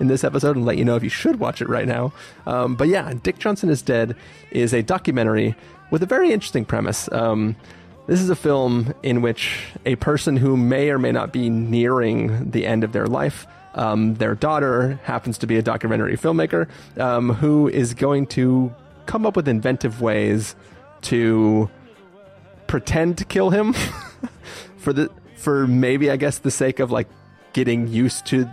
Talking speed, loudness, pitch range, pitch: 185 wpm, -20 LUFS, 115-140 Hz, 125 Hz